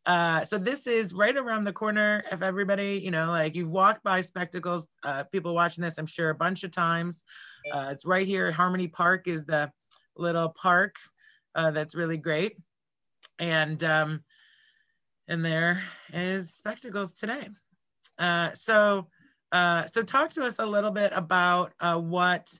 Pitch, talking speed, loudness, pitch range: 180 Hz, 165 wpm, -27 LUFS, 165-200 Hz